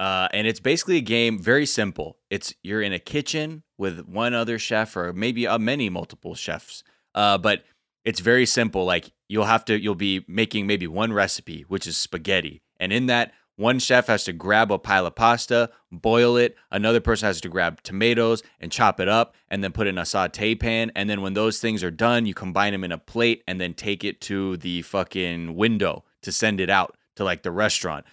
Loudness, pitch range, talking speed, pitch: -23 LUFS, 95-115 Hz, 220 wpm, 105 Hz